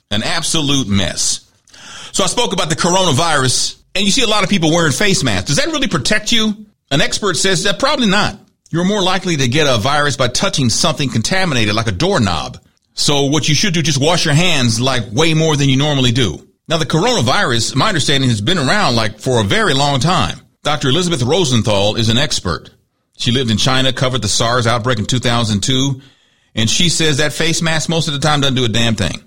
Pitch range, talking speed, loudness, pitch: 125-175 Hz, 215 wpm, -14 LUFS, 145 Hz